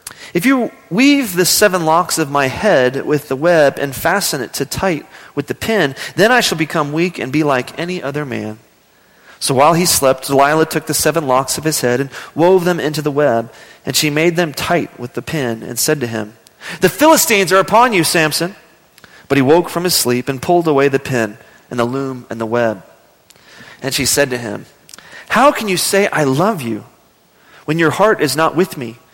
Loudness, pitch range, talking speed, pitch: -14 LUFS, 130-175 Hz, 210 wpm, 155 Hz